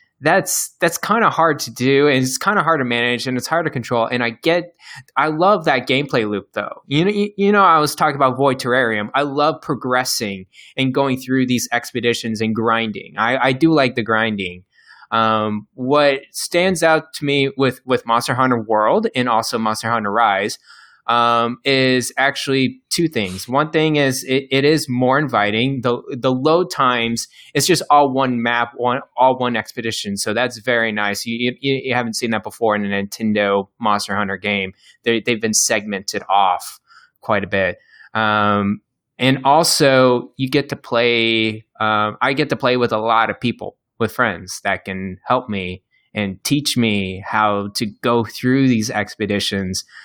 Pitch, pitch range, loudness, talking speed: 120 Hz, 110-135 Hz, -18 LUFS, 185 wpm